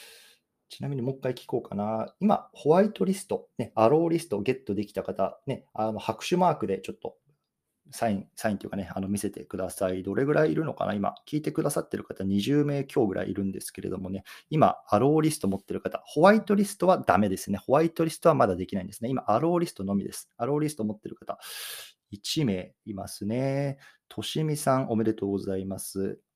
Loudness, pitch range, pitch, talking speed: -28 LUFS, 100-150 Hz, 115 Hz, 435 characters per minute